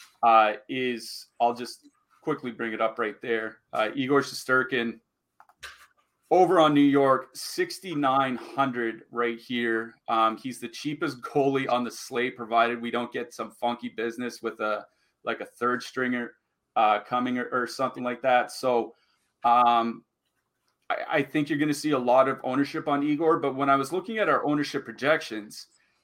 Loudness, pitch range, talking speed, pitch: -26 LUFS, 115-140 Hz, 165 wpm, 125 Hz